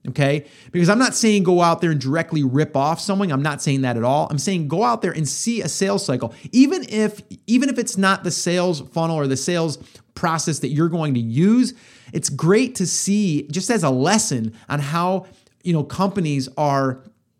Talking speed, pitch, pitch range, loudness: 210 wpm, 165 Hz, 140-195 Hz, -20 LUFS